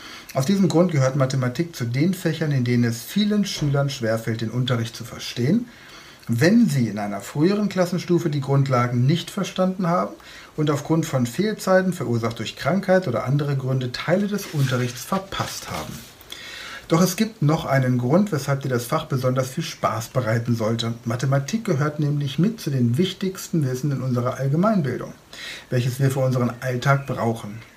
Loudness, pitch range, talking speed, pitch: -22 LUFS, 125-175 Hz, 165 wpm, 140 Hz